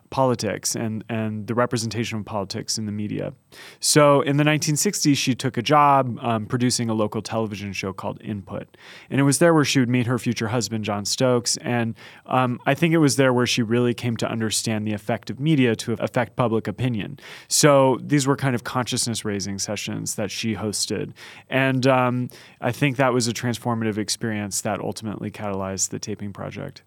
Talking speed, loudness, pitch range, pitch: 190 wpm, -22 LUFS, 105-130 Hz, 120 Hz